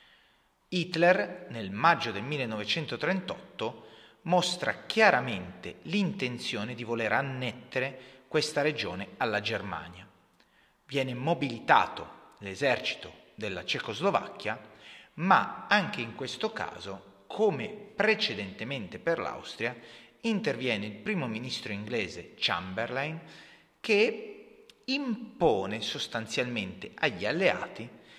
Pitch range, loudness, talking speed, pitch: 115-185 Hz, -30 LUFS, 85 wpm, 135 Hz